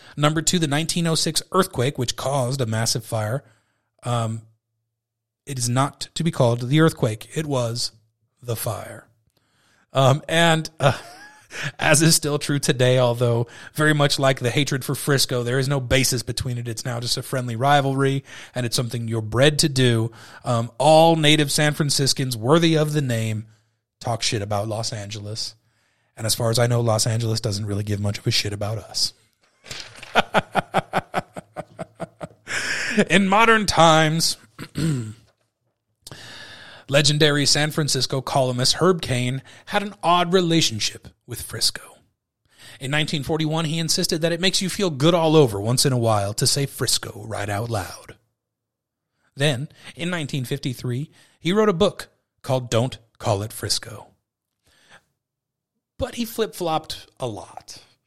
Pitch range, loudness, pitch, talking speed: 115-155 Hz, -21 LUFS, 130 Hz, 150 wpm